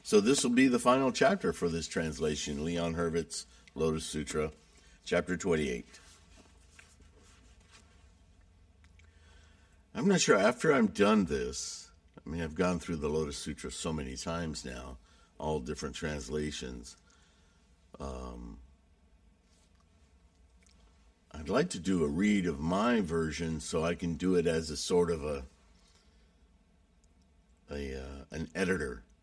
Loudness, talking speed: -32 LUFS, 130 wpm